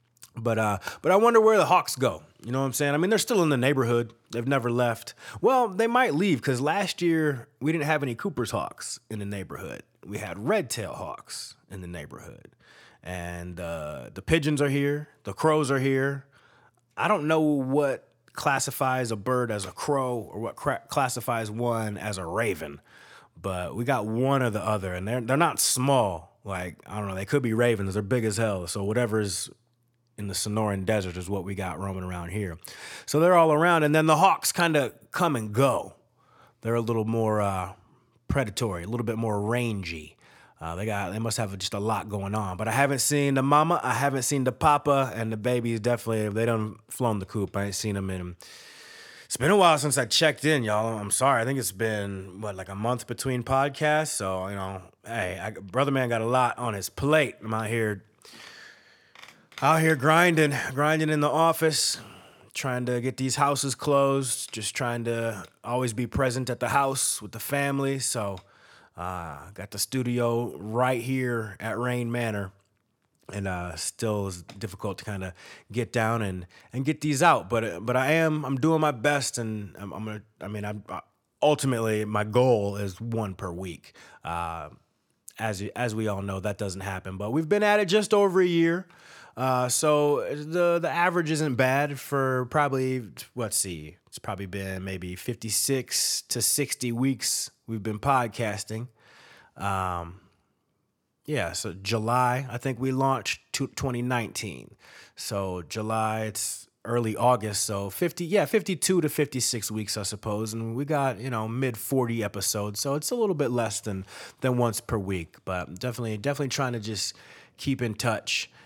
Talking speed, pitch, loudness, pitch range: 190 wpm, 120 Hz, -26 LUFS, 105-140 Hz